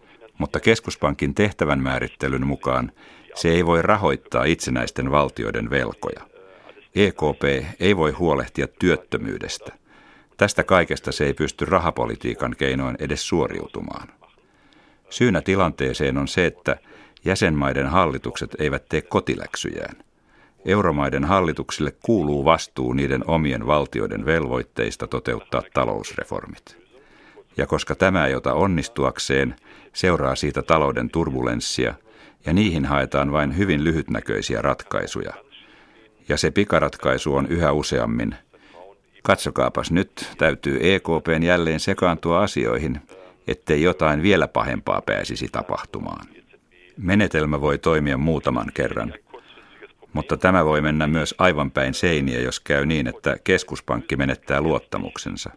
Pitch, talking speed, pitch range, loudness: 75 Hz, 110 wpm, 70-85 Hz, -22 LUFS